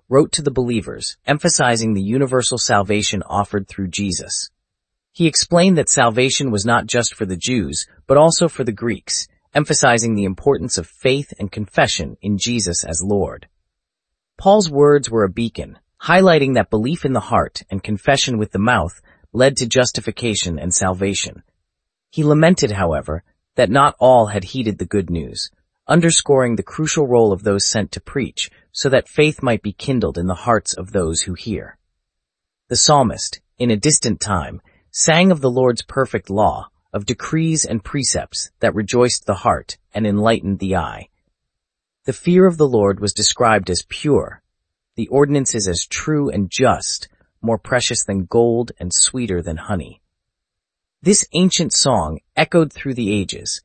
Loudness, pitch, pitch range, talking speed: -17 LUFS, 115 Hz, 95-135 Hz, 160 wpm